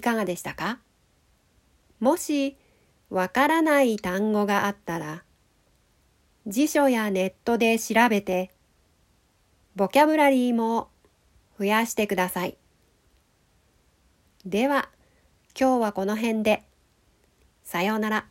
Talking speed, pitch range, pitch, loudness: 205 characters per minute, 185-245 Hz, 215 Hz, -24 LUFS